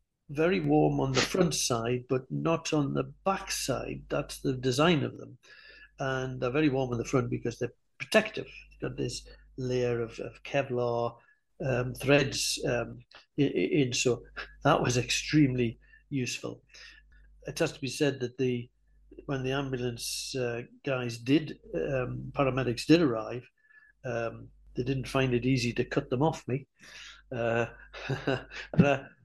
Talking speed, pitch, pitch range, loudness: 150 wpm, 130 Hz, 125-145 Hz, -30 LUFS